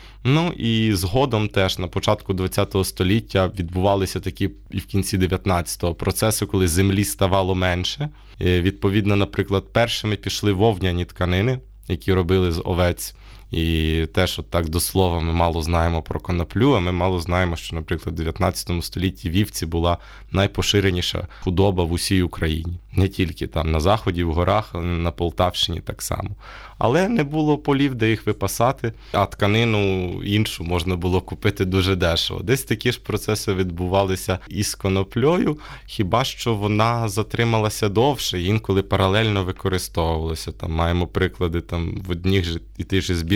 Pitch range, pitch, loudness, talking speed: 90-105 Hz, 95 Hz, -21 LUFS, 150 wpm